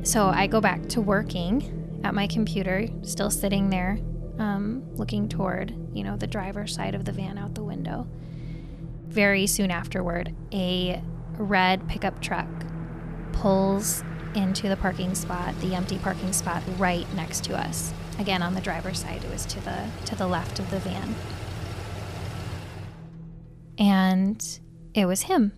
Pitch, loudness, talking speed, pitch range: 175 Hz, -27 LUFS, 150 wpm, 155-195 Hz